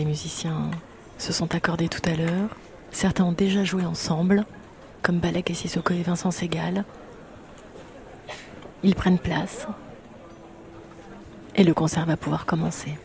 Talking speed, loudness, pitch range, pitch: 135 wpm, -25 LUFS, 165-185 Hz, 175 Hz